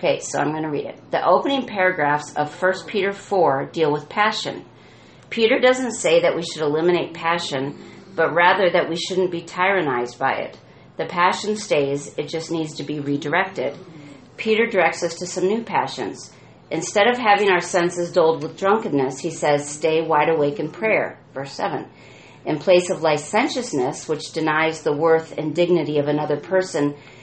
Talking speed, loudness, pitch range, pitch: 175 wpm, -21 LUFS, 150-190 Hz, 170 Hz